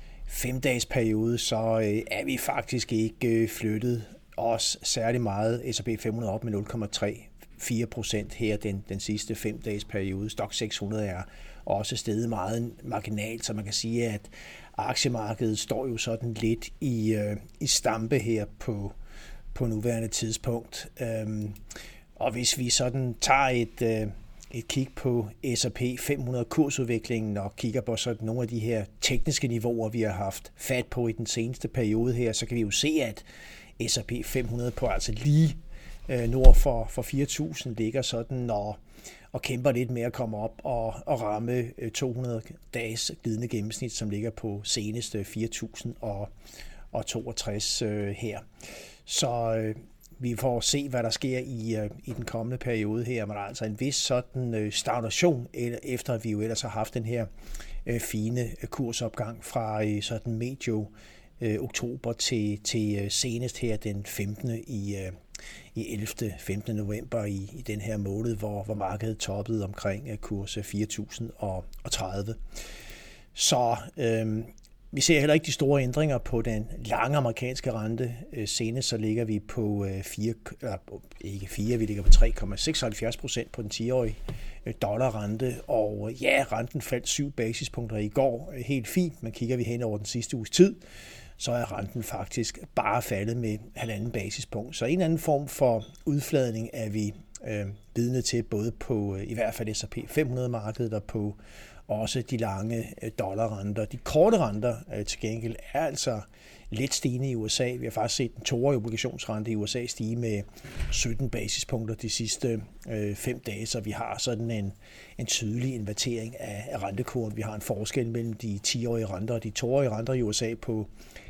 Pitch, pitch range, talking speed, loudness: 115 Hz, 110-125 Hz, 160 wpm, -29 LUFS